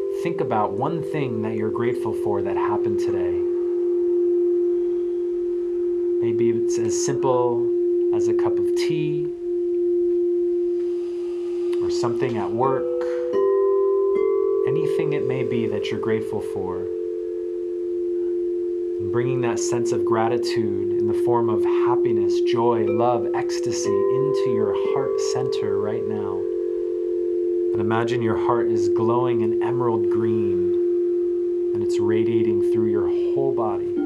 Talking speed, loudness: 120 wpm, -22 LUFS